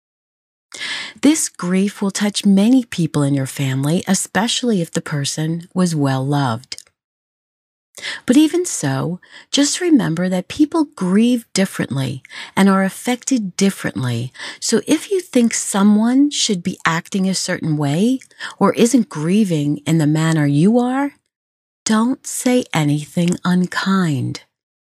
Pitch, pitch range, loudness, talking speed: 190 Hz, 155-240 Hz, -17 LUFS, 125 wpm